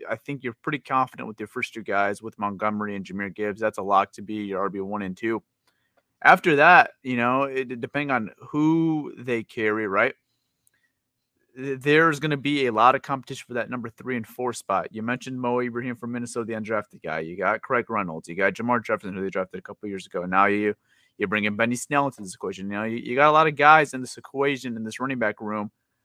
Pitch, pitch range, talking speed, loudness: 120 Hz, 105-130 Hz, 235 wpm, -24 LUFS